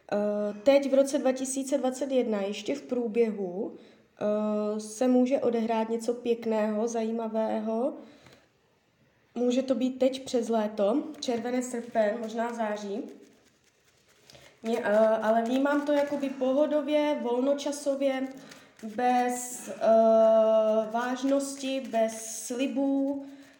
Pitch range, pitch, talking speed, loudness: 225-270 Hz, 245 Hz, 95 wpm, -28 LUFS